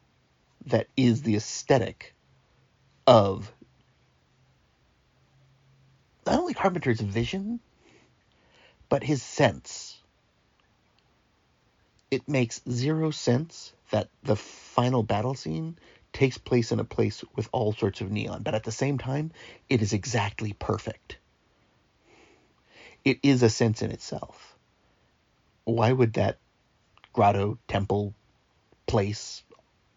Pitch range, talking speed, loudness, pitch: 105-135 Hz, 105 wpm, -27 LUFS, 120 Hz